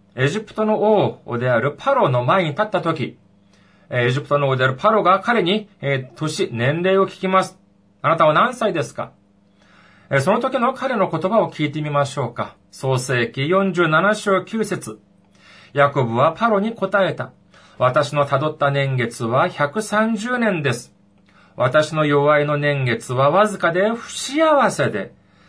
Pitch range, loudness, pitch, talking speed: 130-195 Hz, -19 LUFS, 150 Hz, 255 characters per minute